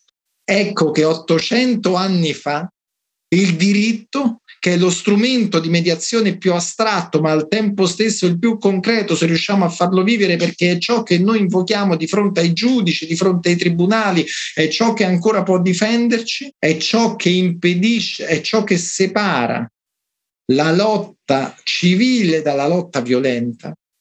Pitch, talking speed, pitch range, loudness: 185 Hz, 150 wpm, 170-215 Hz, -16 LUFS